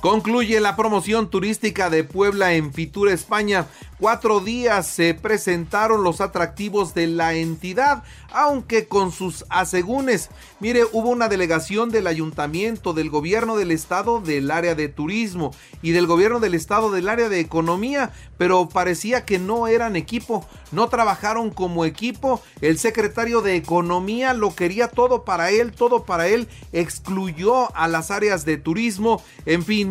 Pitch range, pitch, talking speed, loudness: 170-225 Hz, 200 Hz, 150 wpm, -21 LUFS